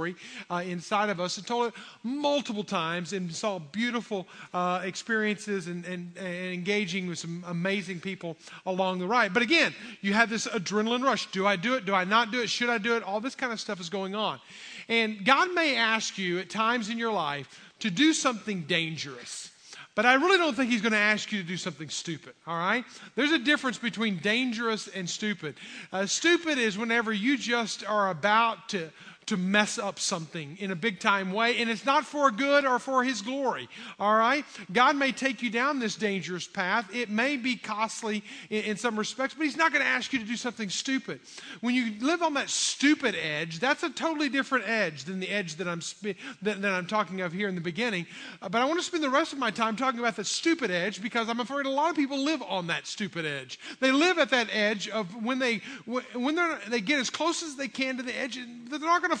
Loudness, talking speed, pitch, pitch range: -28 LUFS, 230 wpm, 225 Hz, 195-260 Hz